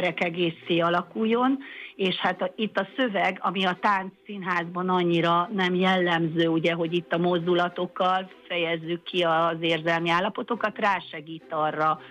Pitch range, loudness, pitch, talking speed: 170-190 Hz, -25 LUFS, 180 Hz, 135 wpm